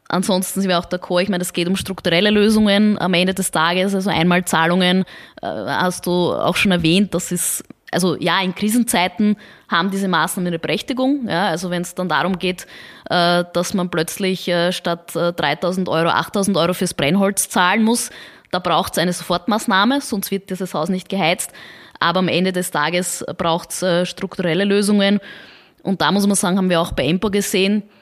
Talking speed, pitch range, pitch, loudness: 180 wpm, 175-200 Hz, 185 Hz, -18 LUFS